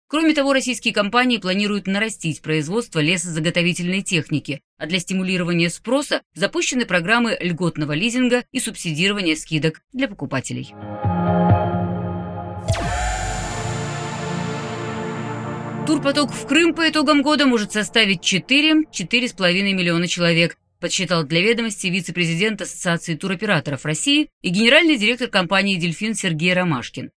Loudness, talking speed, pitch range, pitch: -19 LUFS, 105 wpm, 155-235 Hz, 185 Hz